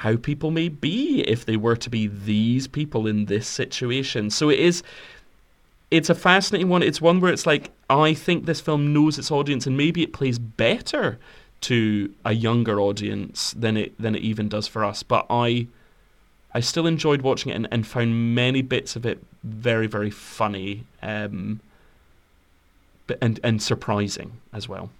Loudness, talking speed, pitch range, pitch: -23 LUFS, 180 wpm, 105-145 Hz, 115 Hz